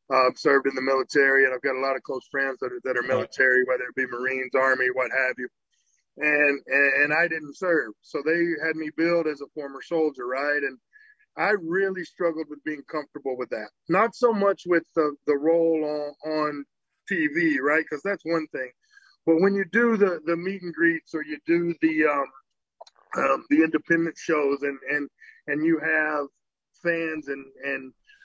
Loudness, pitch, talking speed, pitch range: -24 LUFS, 155 Hz, 200 wpm, 135-170 Hz